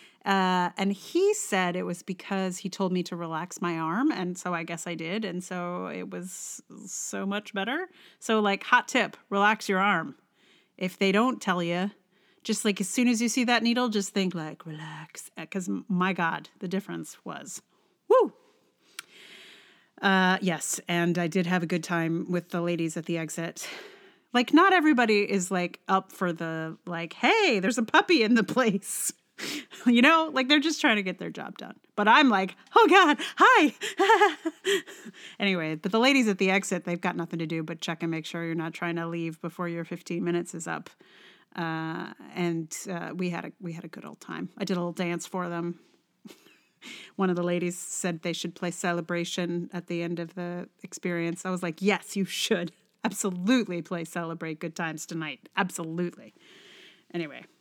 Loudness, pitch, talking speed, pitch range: -27 LUFS, 185 Hz, 190 wpm, 170-215 Hz